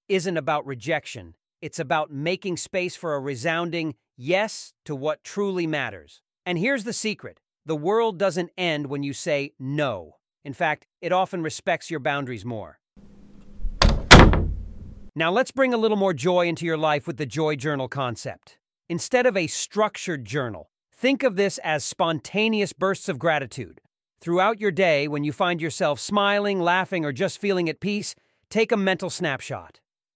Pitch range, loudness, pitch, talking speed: 145-190 Hz, -23 LUFS, 165 Hz, 160 wpm